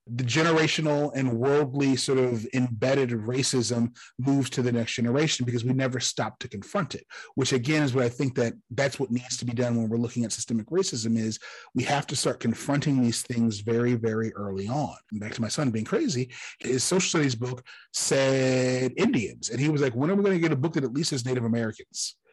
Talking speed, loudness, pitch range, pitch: 220 wpm, -26 LUFS, 120-140 Hz, 125 Hz